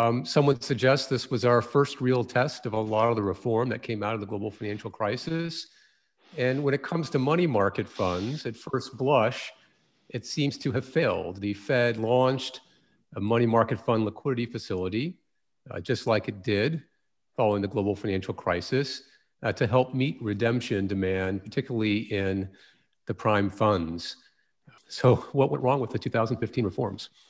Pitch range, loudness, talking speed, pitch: 105-135 Hz, -27 LUFS, 170 wpm, 120 Hz